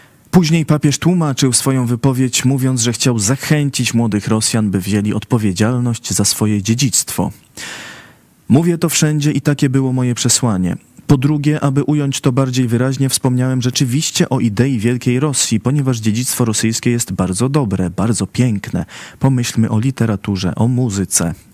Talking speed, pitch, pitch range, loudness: 140 wpm, 125 Hz, 110-140 Hz, -15 LUFS